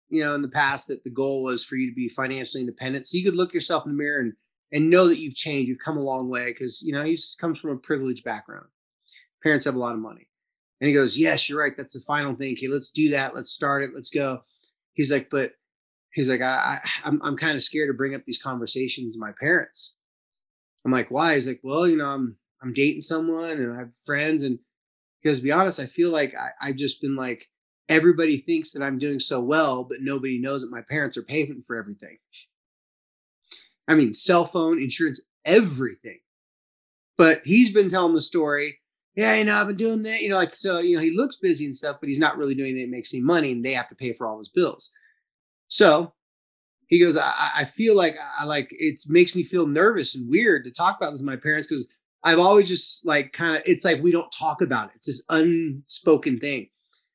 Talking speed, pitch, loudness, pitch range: 235 wpm, 145 Hz, -23 LUFS, 130-165 Hz